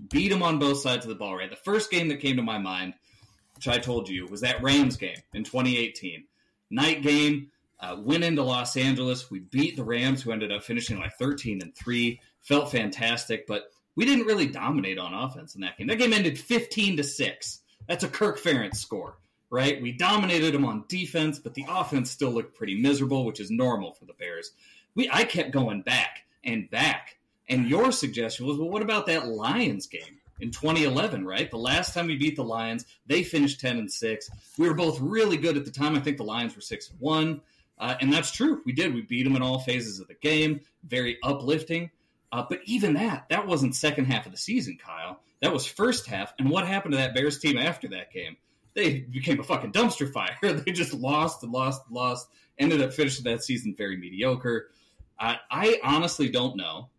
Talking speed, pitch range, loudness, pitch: 215 wpm, 120-155 Hz, -27 LUFS, 135 Hz